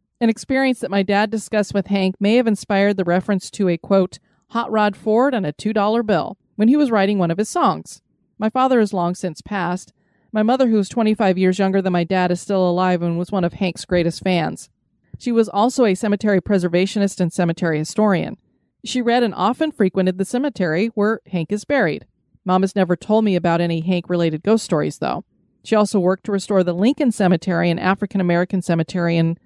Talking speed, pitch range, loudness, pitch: 210 wpm, 180-220 Hz, -19 LUFS, 195 Hz